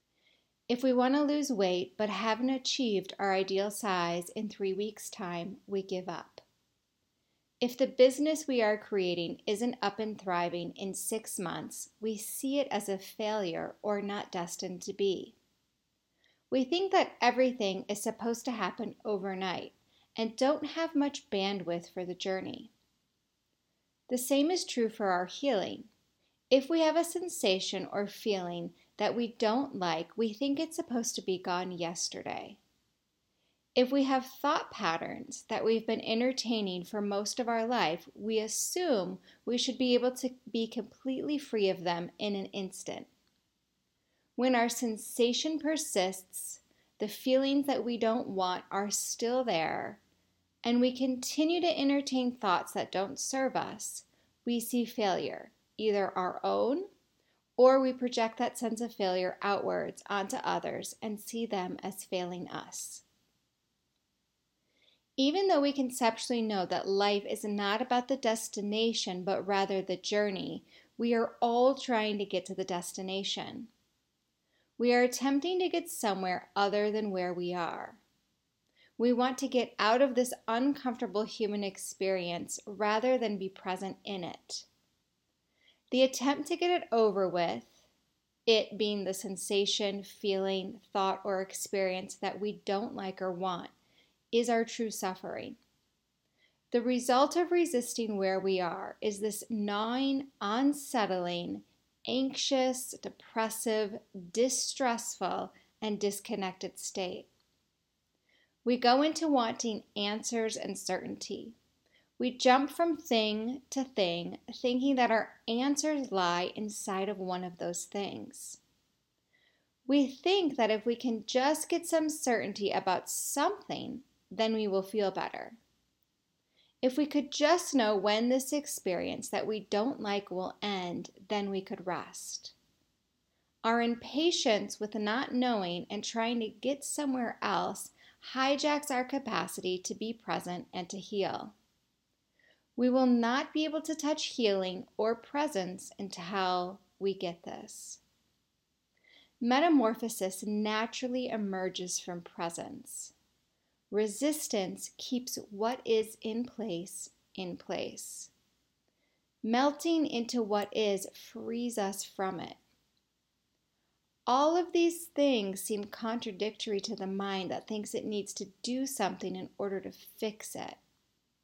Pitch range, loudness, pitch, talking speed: 195-255 Hz, -32 LUFS, 220 Hz, 135 wpm